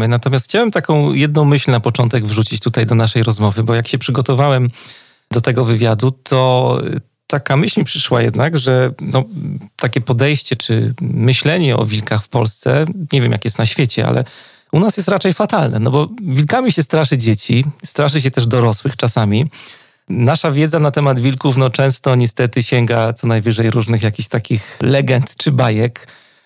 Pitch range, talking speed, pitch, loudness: 115-145 Hz, 170 wpm, 130 Hz, -15 LUFS